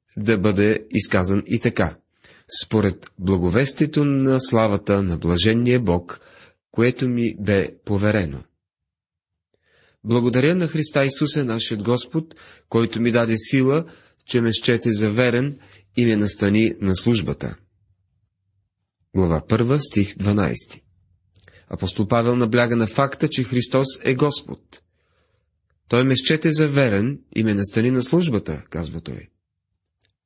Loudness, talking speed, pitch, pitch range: -20 LUFS, 120 wpm, 110 Hz, 95-125 Hz